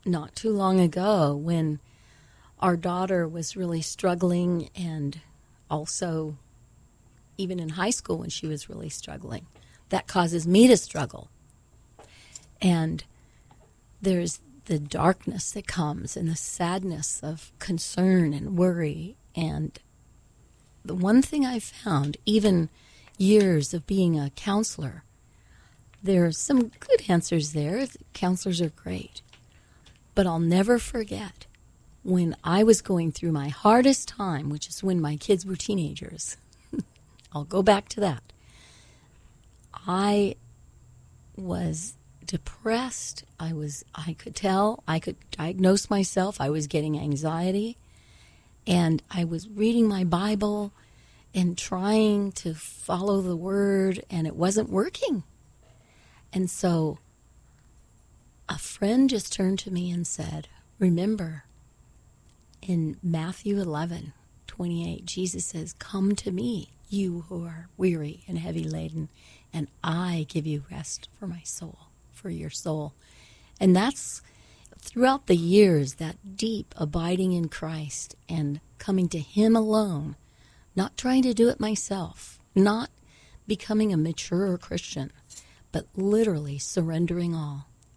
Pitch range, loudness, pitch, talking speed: 155-200 Hz, -26 LUFS, 175 Hz, 125 wpm